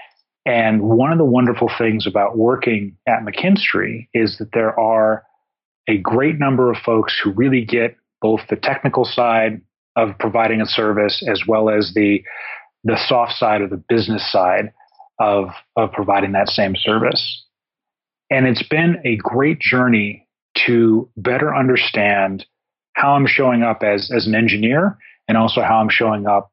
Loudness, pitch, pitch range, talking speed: -17 LUFS, 115 Hz, 105-125 Hz, 160 wpm